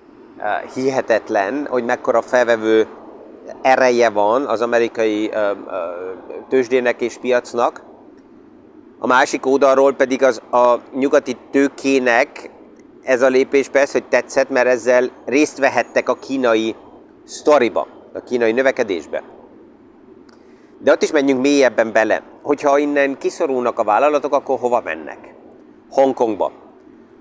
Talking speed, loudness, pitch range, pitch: 110 wpm, -17 LUFS, 120-145 Hz, 135 Hz